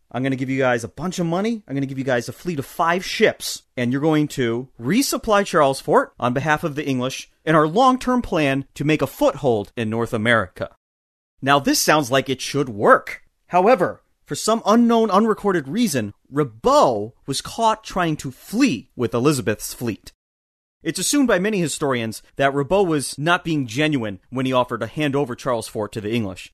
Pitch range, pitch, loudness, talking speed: 120-175 Hz, 140 Hz, -20 LUFS, 200 wpm